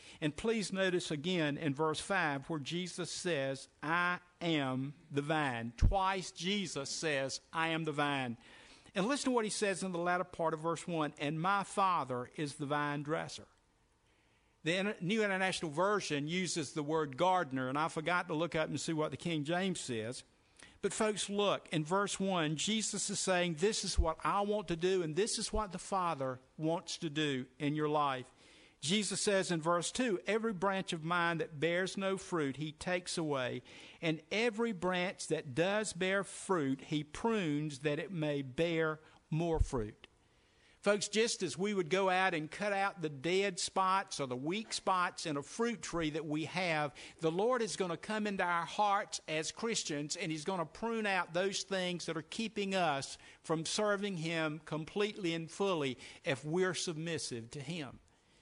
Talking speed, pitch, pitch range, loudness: 185 wpm, 170 Hz, 155-195 Hz, -36 LUFS